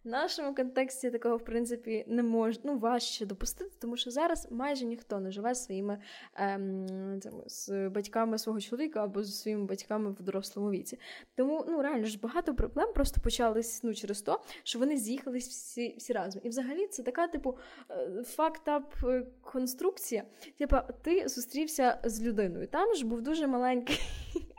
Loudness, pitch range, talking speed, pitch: -34 LUFS, 220-280 Hz, 160 wpm, 245 Hz